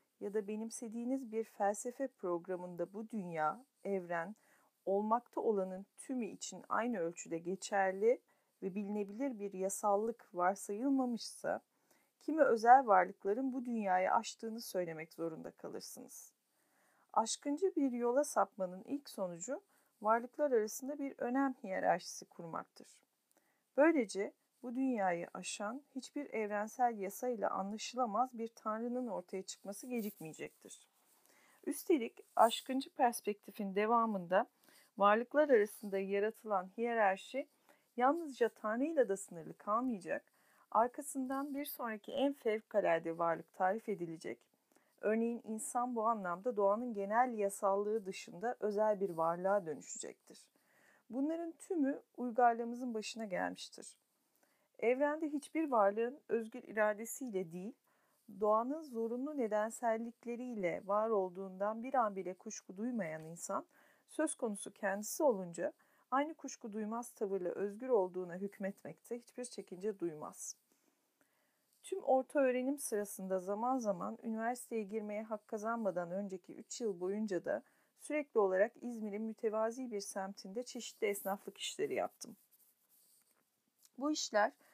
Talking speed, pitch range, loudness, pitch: 110 wpm, 200-255 Hz, -38 LUFS, 225 Hz